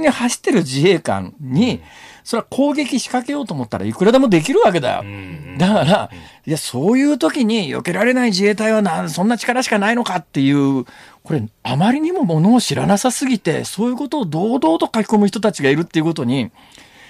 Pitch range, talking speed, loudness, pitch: 155-245 Hz, 405 characters per minute, -17 LUFS, 210 Hz